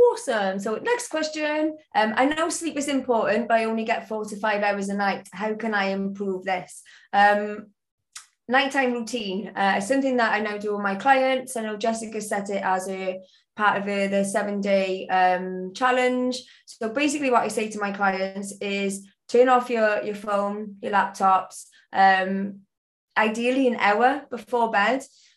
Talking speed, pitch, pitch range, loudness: 175 wpm, 210 Hz, 195-245 Hz, -24 LUFS